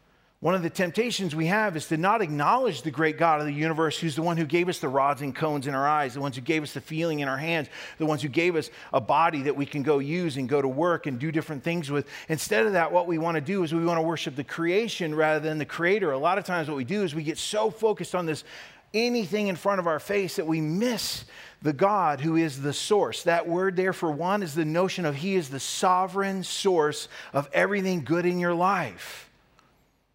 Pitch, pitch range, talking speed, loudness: 165 Hz, 150-185 Hz, 255 wpm, -26 LUFS